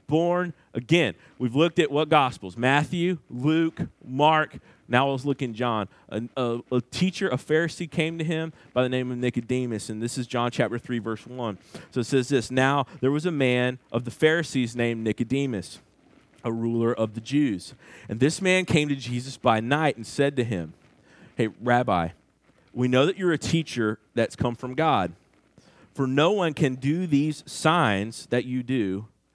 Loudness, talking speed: -25 LUFS, 185 wpm